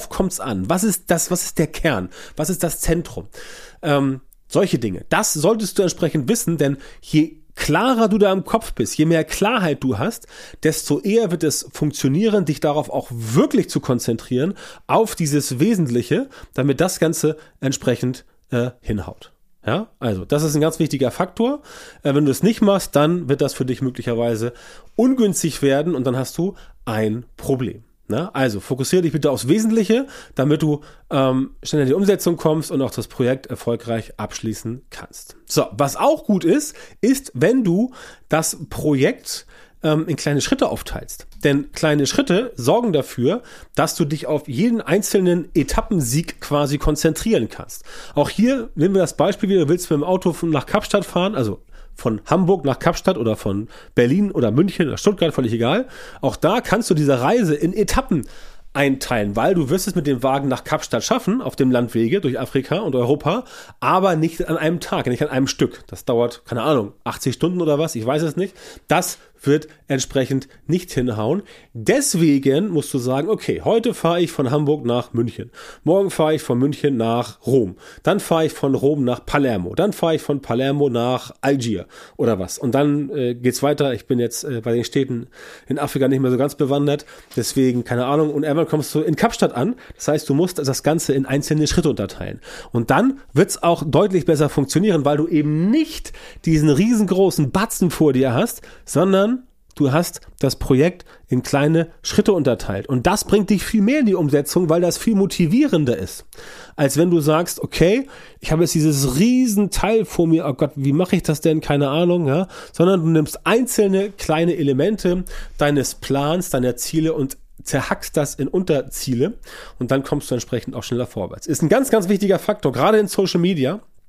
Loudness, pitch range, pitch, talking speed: -19 LUFS, 135-180 Hz, 155 Hz, 185 wpm